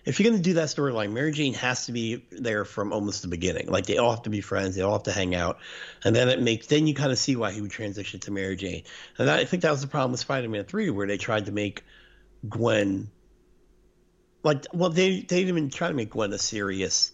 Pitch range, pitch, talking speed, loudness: 100-145 Hz, 110 Hz, 265 wpm, -26 LUFS